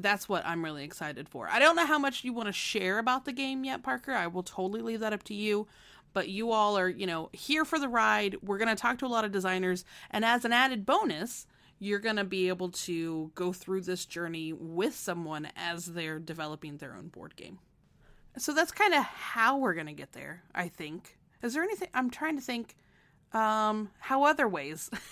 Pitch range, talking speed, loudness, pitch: 175-250 Hz, 225 wpm, -31 LUFS, 205 Hz